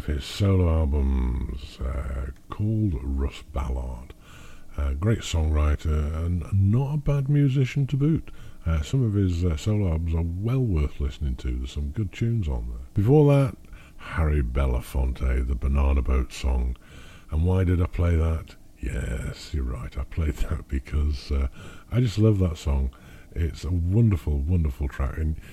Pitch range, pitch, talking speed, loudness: 70-95 Hz, 80 Hz, 160 wpm, -26 LUFS